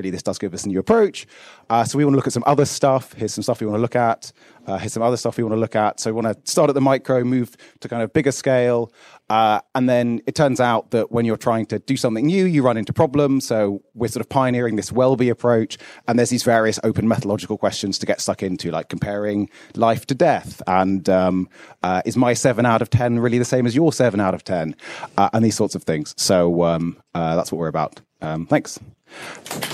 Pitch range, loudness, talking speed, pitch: 105-125 Hz, -20 LUFS, 250 wpm, 115 Hz